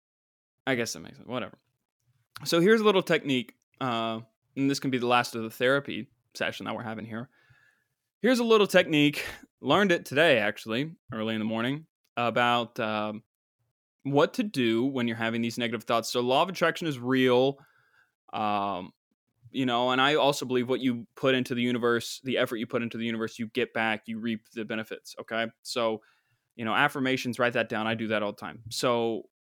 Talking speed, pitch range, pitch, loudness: 200 wpm, 115-130 Hz, 120 Hz, -27 LUFS